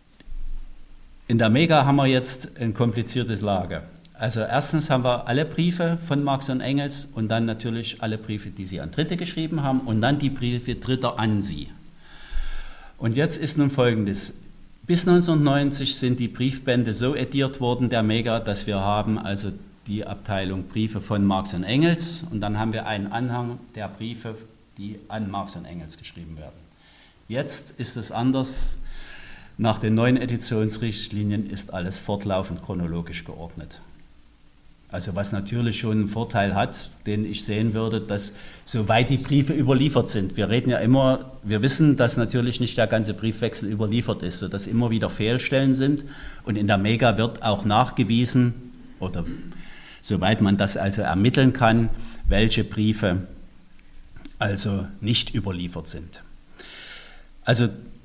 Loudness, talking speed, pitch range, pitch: -23 LUFS, 155 wpm, 100-130 Hz, 115 Hz